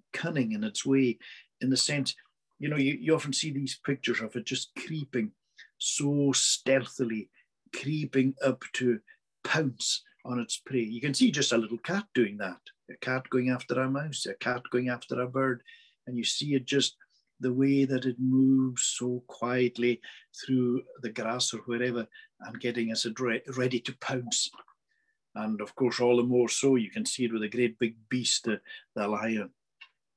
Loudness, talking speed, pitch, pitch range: -29 LUFS, 180 wpm, 130 Hz, 120-140 Hz